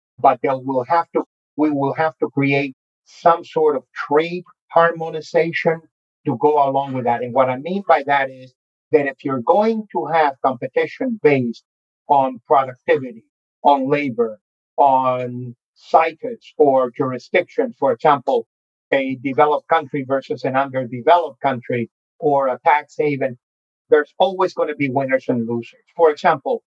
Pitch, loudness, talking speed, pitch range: 150 Hz, -19 LUFS, 150 wpm, 135-170 Hz